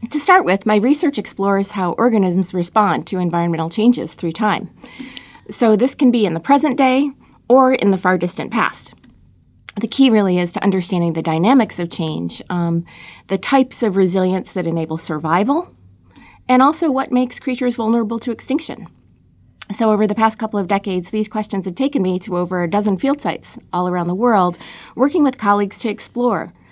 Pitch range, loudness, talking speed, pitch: 180-250 Hz, -16 LUFS, 180 wpm, 210 Hz